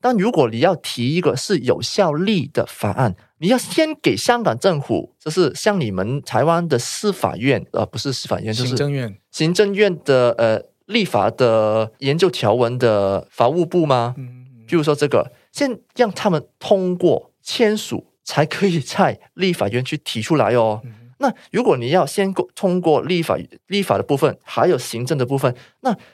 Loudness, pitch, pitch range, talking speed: -19 LUFS, 145 Hz, 120-185 Hz, 255 characters per minute